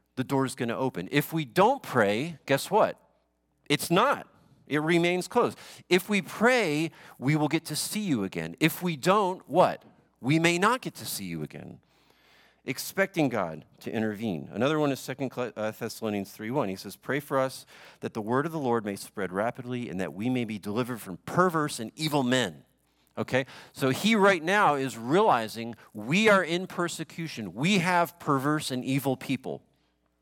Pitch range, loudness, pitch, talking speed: 115-170 Hz, -27 LUFS, 135 Hz, 180 wpm